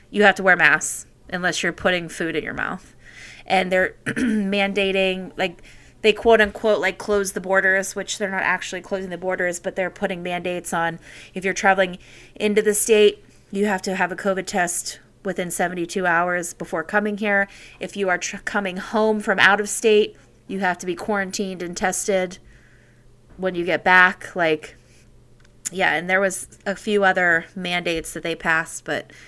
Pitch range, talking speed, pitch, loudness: 175-200 Hz, 180 wpm, 185 Hz, -21 LUFS